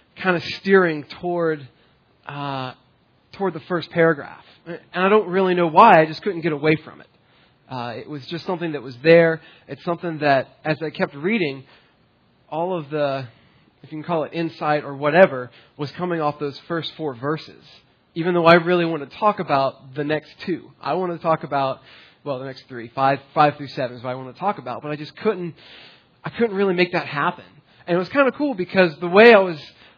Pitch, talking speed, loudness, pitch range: 155 Hz, 215 wpm, -20 LUFS, 140-175 Hz